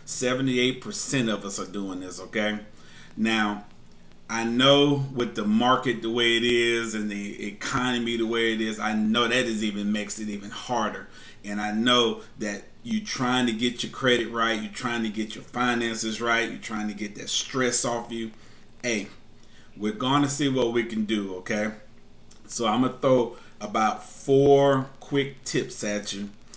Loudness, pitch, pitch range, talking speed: -25 LUFS, 115 Hz, 105-125 Hz, 175 wpm